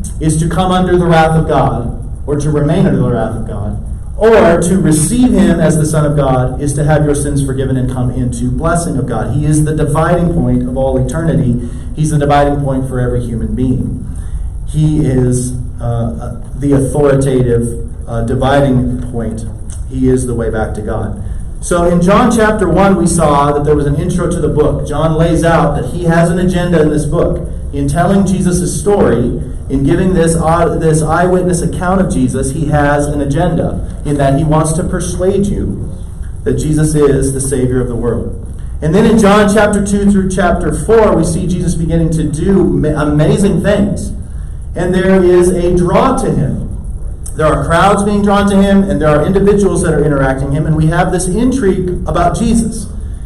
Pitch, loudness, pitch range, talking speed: 150 Hz, -12 LUFS, 125-175 Hz, 195 wpm